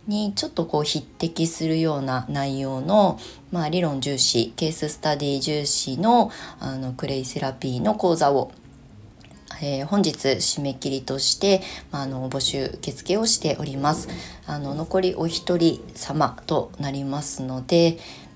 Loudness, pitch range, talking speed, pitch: -23 LUFS, 135-170 Hz, 280 characters per minute, 145 Hz